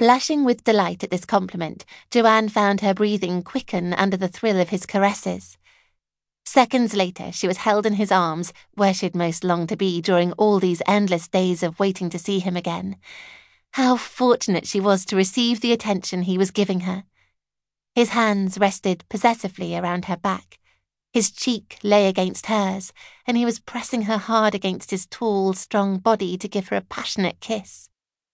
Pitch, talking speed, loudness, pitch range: 195 Hz, 175 wpm, -21 LUFS, 180-220 Hz